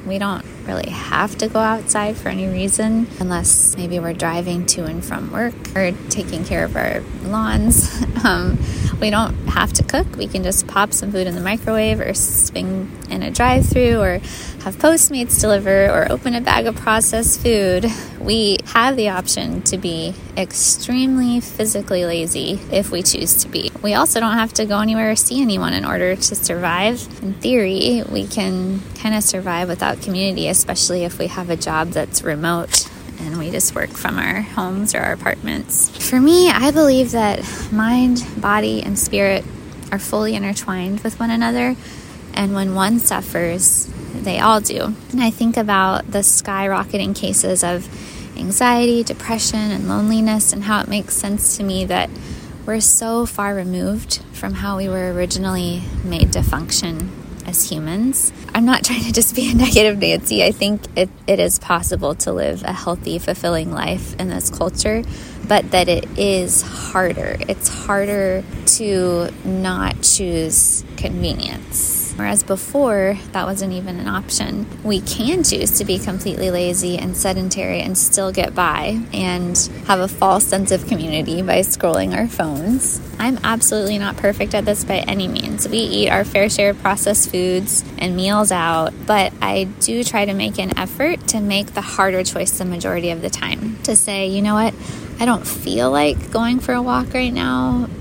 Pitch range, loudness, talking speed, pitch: 185-225 Hz, -17 LUFS, 175 wpm, 200 Hz